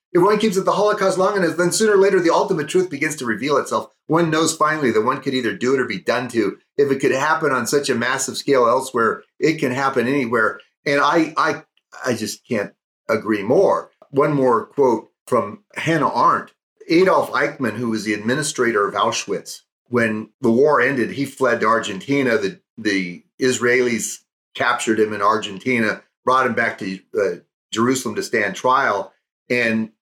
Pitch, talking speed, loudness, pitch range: 135 Hz, 185 wpm, -19 LUFS, 115-180 Hz